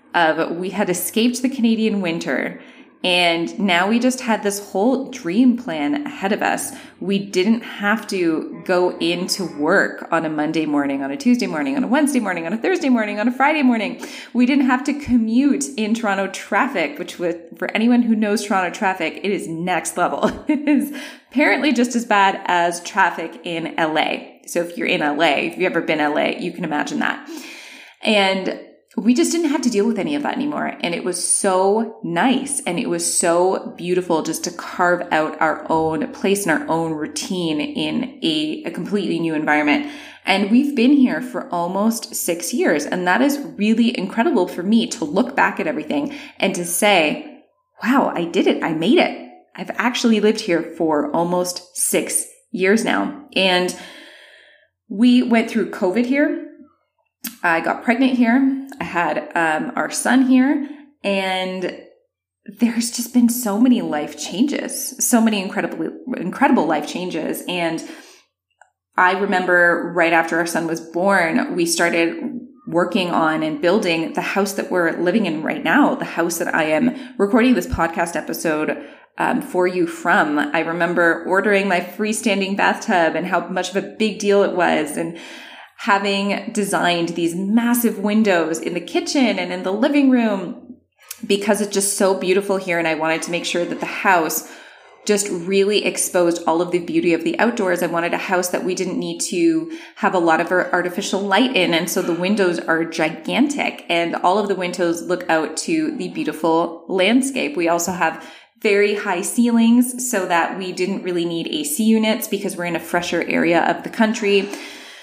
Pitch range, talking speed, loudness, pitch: 175-250 Hz, 180 wpm, -19 LUFS, 200 Hz